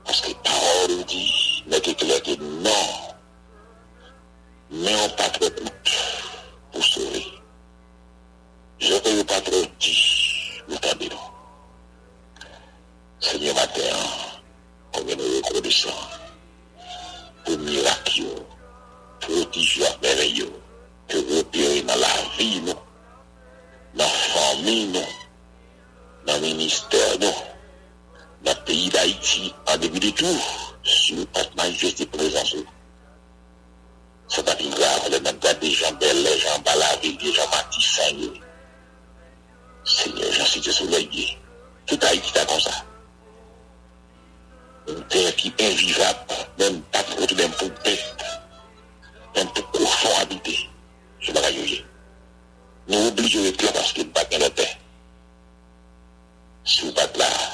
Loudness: -21 LUFS